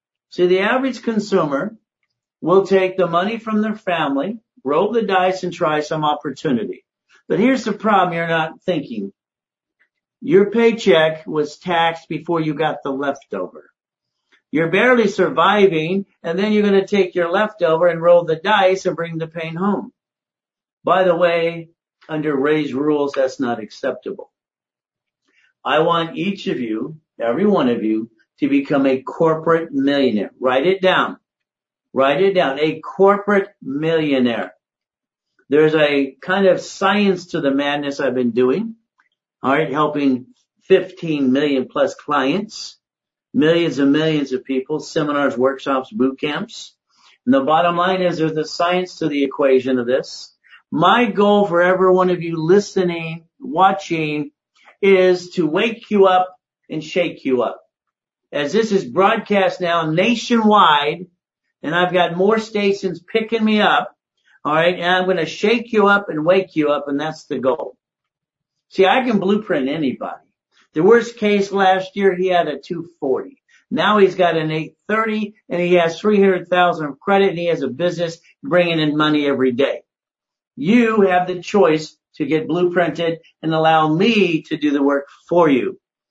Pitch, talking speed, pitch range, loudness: 175 Hz, 155 wpm, 155-195 Hz, -17 LUFS